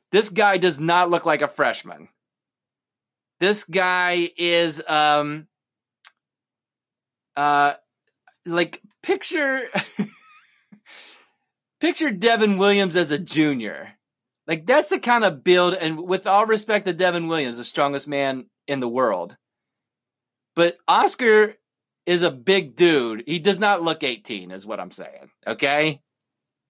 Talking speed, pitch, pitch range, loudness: 125 wpm, 170 Hz, 145-205 Hz, -20 LUFS